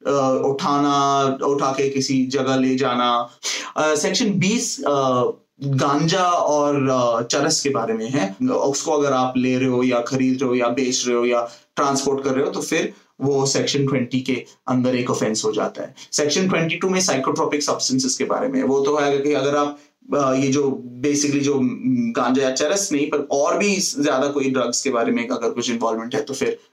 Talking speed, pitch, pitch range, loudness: 200 wpm, 140 Hz, 130-150 Hz, -20 LUFS